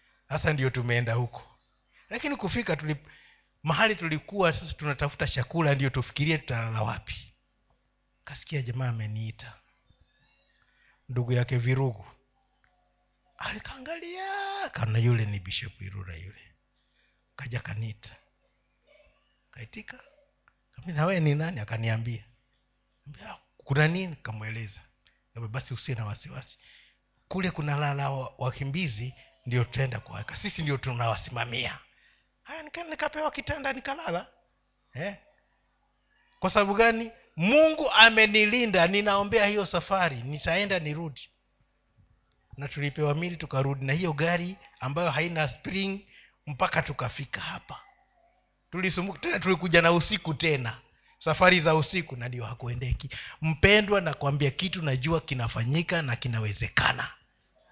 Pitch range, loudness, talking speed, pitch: 125-185 Hz, -27 LUFS, 95 wpm, 145 Hz